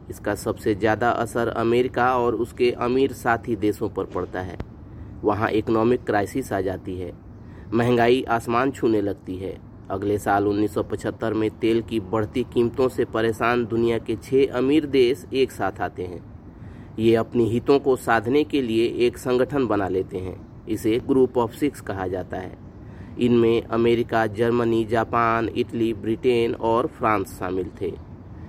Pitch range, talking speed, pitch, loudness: 105-120 Hz, 150 wpm, 115 Hz, -23 LUFS